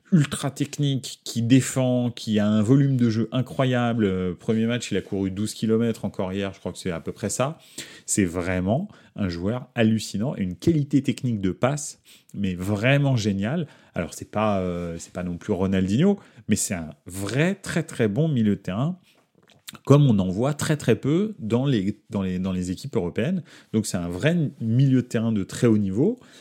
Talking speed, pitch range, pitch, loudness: 195 wpm, 100-140 Hz, 115 Hz, -24 LUFS